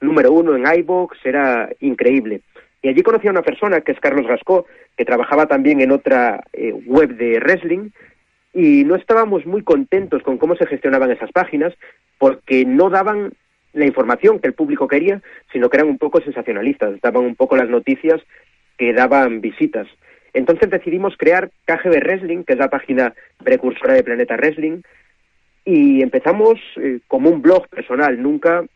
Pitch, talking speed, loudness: 175 Hz, 165 wpm, -16 LUFS